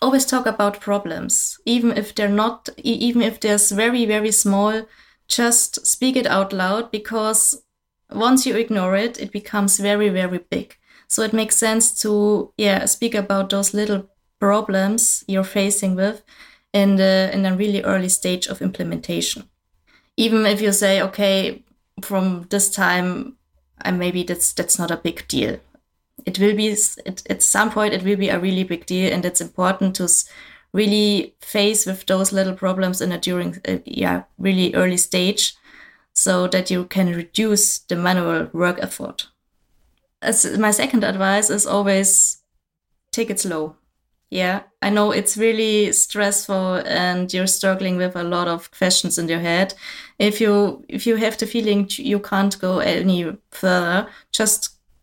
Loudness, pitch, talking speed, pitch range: -19 LUFS, 200 Hz, 160 wpm, 185-215 Hz